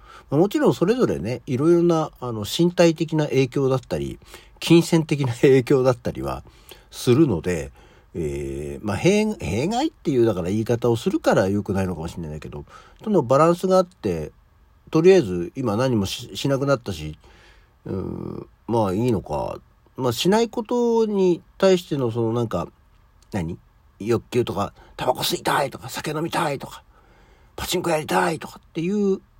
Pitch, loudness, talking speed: 125 Hz, -22 LUFS, 330 characters per minute